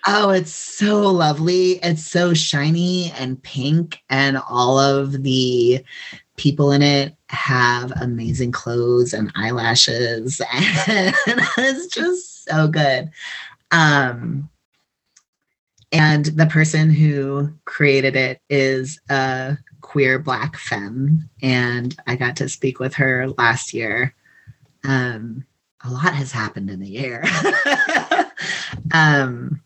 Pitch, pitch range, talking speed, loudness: 140 Hz, 125-155 Hz, 115 wpm, -18 LUFS